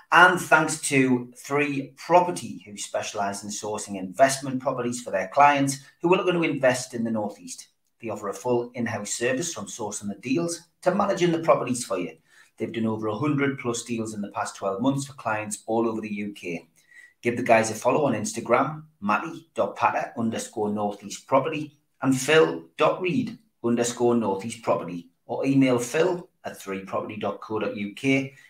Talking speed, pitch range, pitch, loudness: 160 wpm, 105-145 Hz, 120 Hz, -25 LUFS